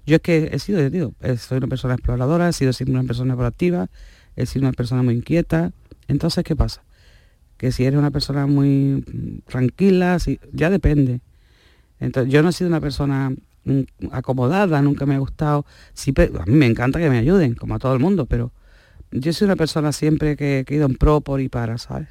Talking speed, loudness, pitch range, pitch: 205 wpm, -20 LUFS, 125-155 Hz, 135 Hz